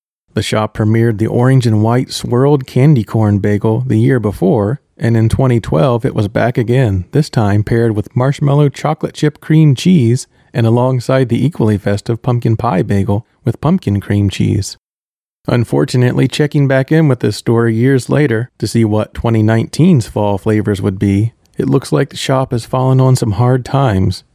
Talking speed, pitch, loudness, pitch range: 175 wpm, 120 Hz, -13 LUFS, 110-135 Hz